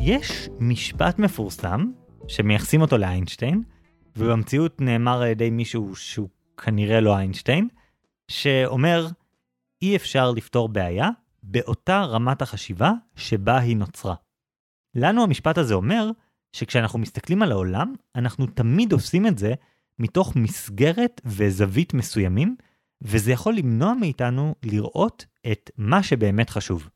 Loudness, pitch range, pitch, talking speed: -23 LUFS, 110-165 Hz, 125 Hz, 115 wpm